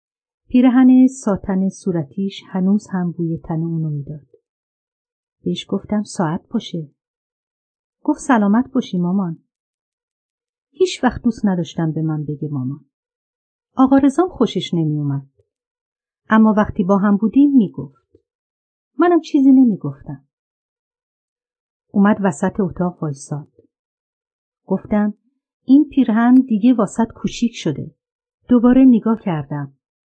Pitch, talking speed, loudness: 220 Hz, 110 wpm, -17 LUFS